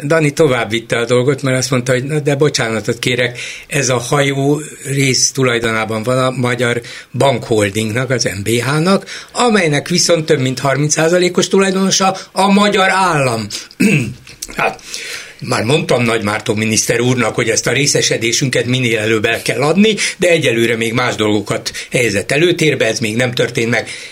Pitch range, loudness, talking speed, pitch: 120-160 Hz, -14 LUFS, 150 wpm, 130 Hz